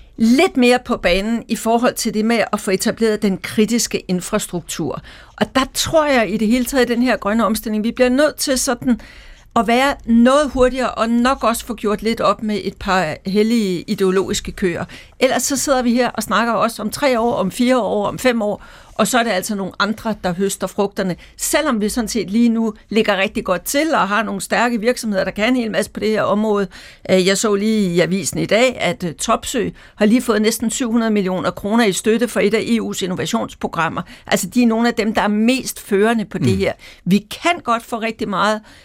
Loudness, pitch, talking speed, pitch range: -17 LUFS, 220 Hz, 220 wpm, 195-235 Hz